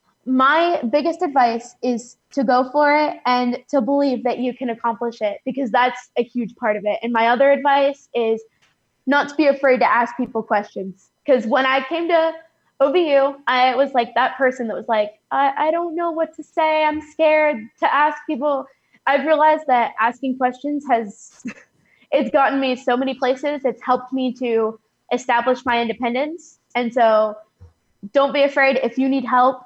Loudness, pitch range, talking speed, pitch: -19 LUFS, 240-285 Hz, 180 wpm, 260 Hz